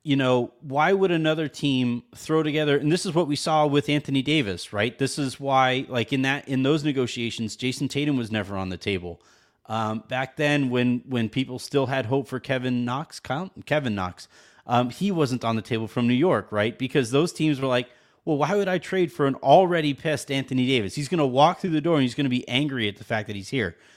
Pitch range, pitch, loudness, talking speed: 120-150 Hz, 135 Hz, -24 LUFS, 235 wpm